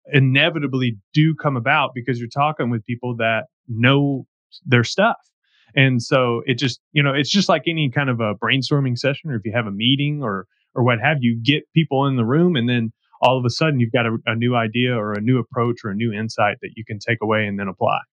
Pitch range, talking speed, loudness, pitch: 115-140 Hz, 240 wpm, -19 LUFS, 125 Hz